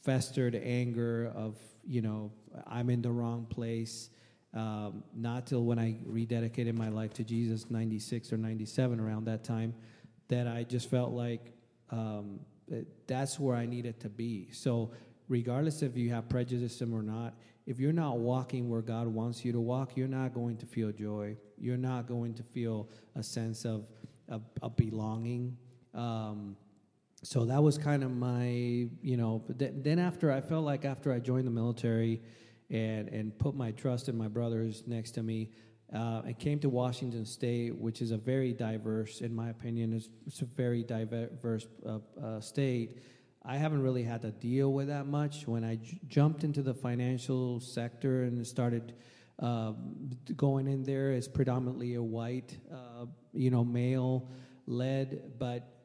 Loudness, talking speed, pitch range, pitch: -35 LUFS, 170 wpm, 115-130 Hz, 120 Hz